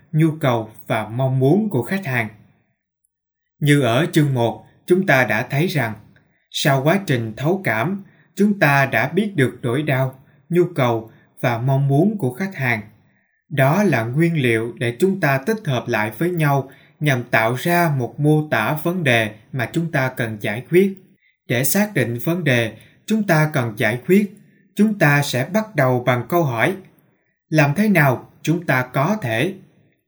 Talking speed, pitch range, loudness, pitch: 175 wpm, 125-170 Hz, -19 LUFS, 145 Hz